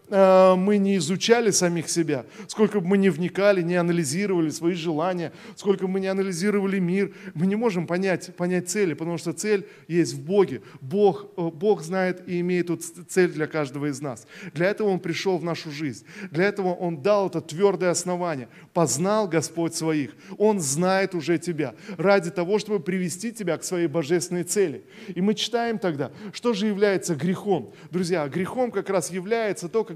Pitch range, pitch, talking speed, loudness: 170-200 Hz, 185 Hz, 175 wpm, -24 LUFS